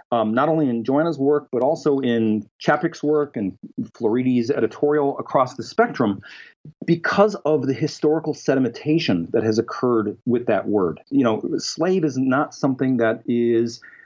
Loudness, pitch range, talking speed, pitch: -21 LUFS, 120-155 Hz, 155 wpm, 140 Hz